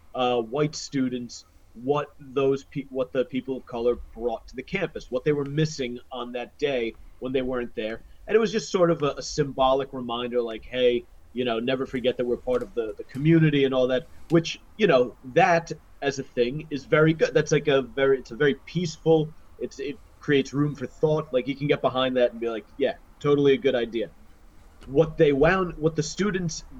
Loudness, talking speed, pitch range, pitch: -25 LUFS, 215 wpm, 125-155 Hz, 135 Hz